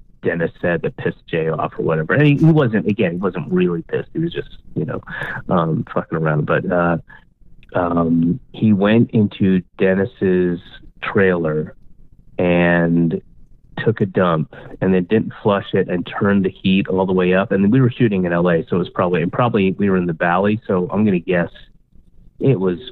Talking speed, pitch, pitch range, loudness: 190 wpm, 95 Hz, 85-105 Hz, -18 LUFS